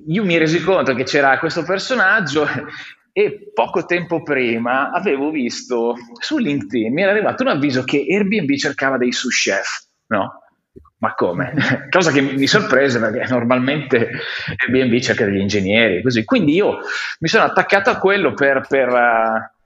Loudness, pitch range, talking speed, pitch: -17 LUFS, 125-190 Hz, 155 wpm, 140 Hz